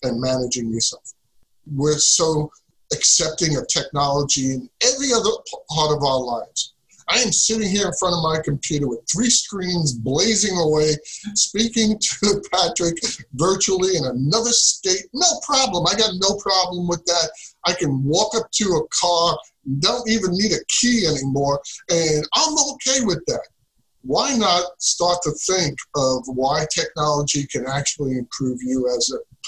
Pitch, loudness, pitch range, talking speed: 170 Hz, -19 LUFS, 140-205 Hz, 155 wpm